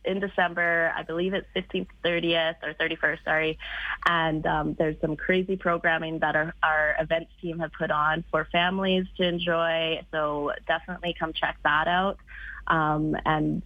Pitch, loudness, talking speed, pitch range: 165 Hz, -26 LUFS, 160 wpm, 155-175 Hz